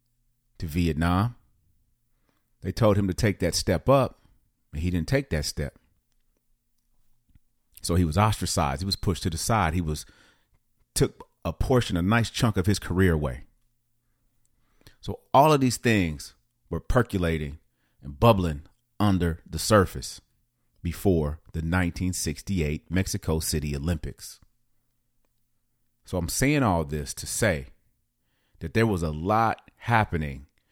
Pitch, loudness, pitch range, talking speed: 95 Hz, -26 LUFS, 85-120 Hz, 140 wpm